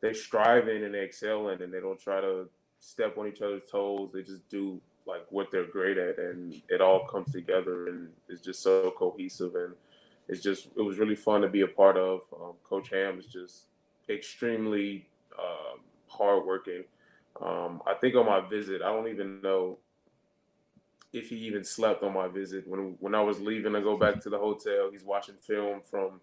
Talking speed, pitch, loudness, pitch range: 195 wpm, 100 Hz, -30 LUFS, 95-115 Hz